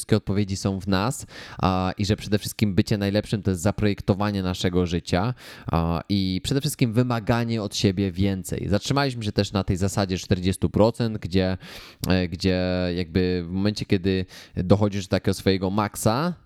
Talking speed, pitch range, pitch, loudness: 155 wpm, 95-105 Hz, 100 Hz, -24 LUFS